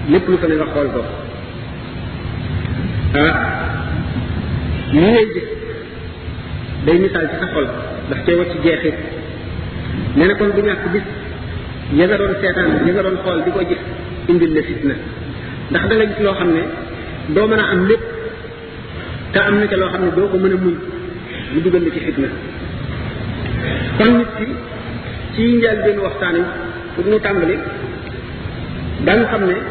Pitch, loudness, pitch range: 185 Hz, -17 LUFS, 165-210 Hz